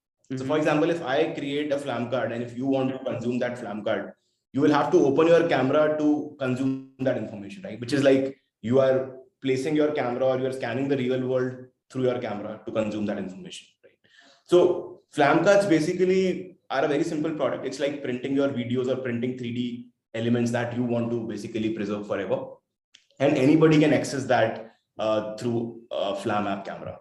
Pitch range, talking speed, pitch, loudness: 120-145 Hz, 200 wpm, 130 Hz, -25 LUFS